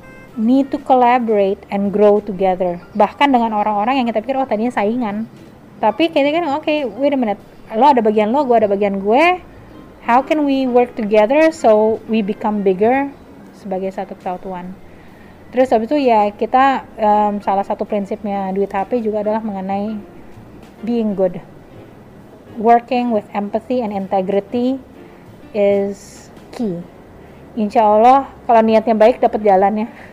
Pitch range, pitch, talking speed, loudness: 205-250 Hz, 220 Hz, 145 wpm, -16 LUFS